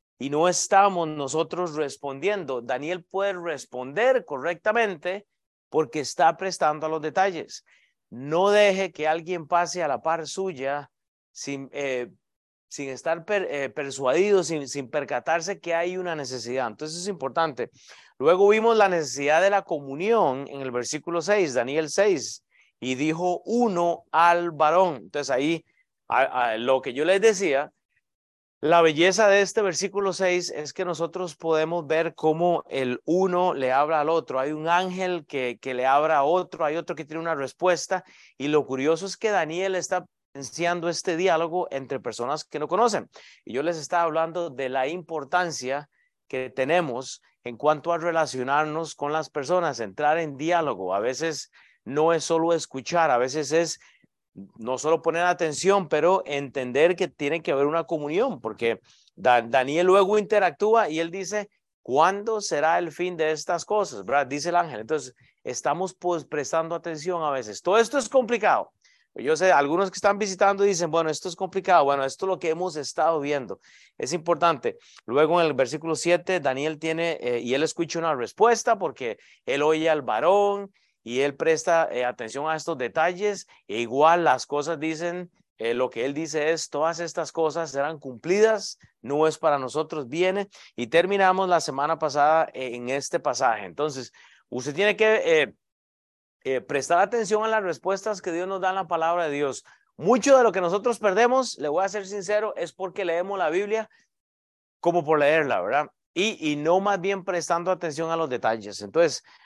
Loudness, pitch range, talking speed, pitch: -24 LUFS, 145-185 Hz, 175 wpm, 165 Hz